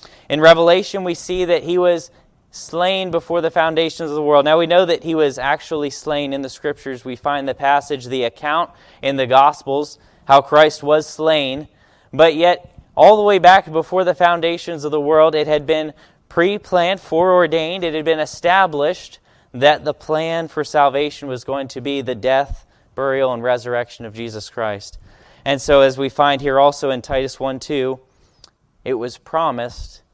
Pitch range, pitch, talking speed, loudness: 135-165 Hz, 150 Hz, 175 wpm, -16 LUFS